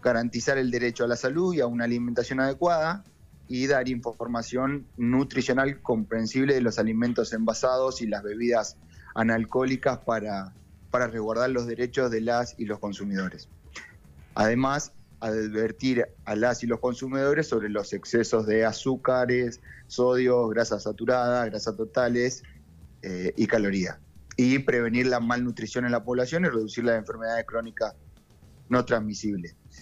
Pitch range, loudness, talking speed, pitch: 110-125 Hz, -27 LUFS, 135 wpm, 120 Hz